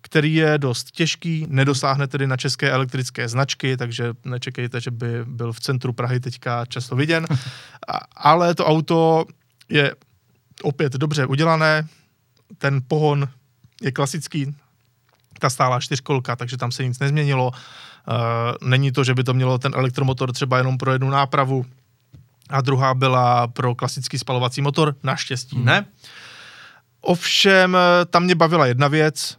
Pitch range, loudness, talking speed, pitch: 125-150 Hz, -20 LUFS, 140 wpm, 135 Hz